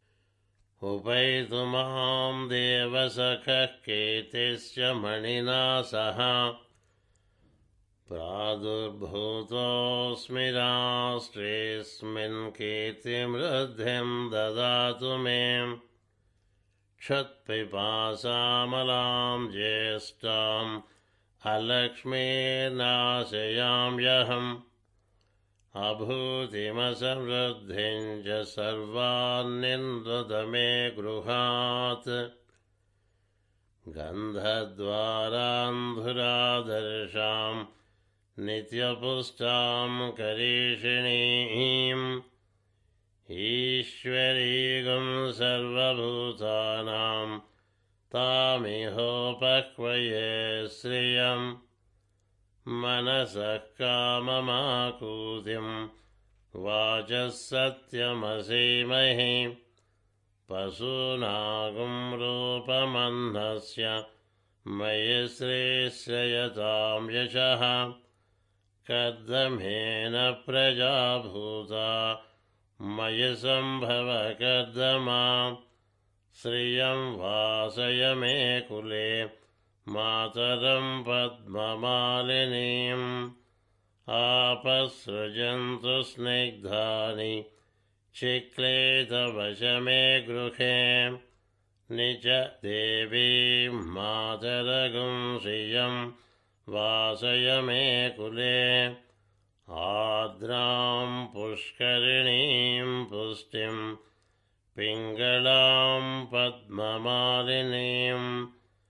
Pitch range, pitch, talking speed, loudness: 110-125 Hz, 120 Hz, 35 wpm, -28 LUFS